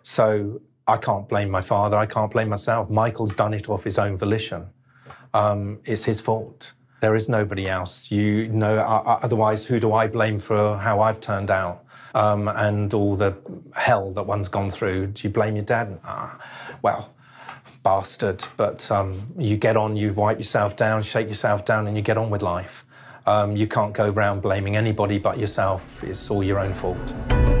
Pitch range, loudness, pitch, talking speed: 100-110 Hz, -23 LUFS, 105 Hz, 185 wpm